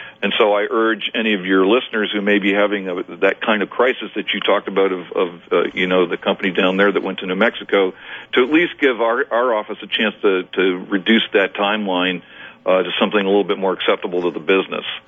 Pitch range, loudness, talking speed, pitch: 95-105 Hz, -18 LUFS, 235 wpm, 100 Hz